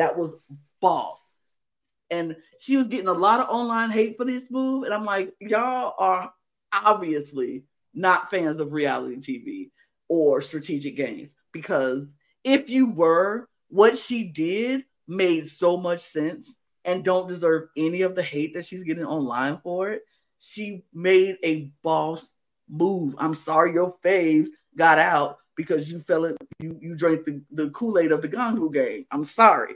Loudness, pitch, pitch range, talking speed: -24 LUFS, 175 Hz, 155-215 Hz, 160 wpm